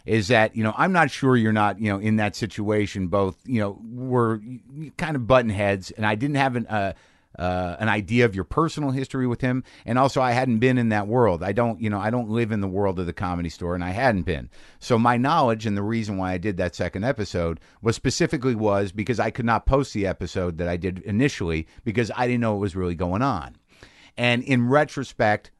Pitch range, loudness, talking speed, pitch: 95-125 Hz, -23 LUFS, 235 wpm, 110 Hz